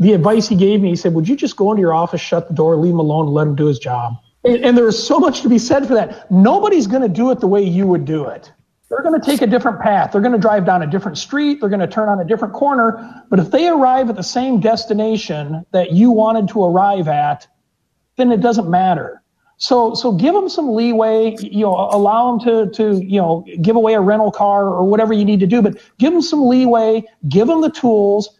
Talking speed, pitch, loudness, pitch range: 260 wpm, 215 Hz, -14 LUFS, 190-240 Hz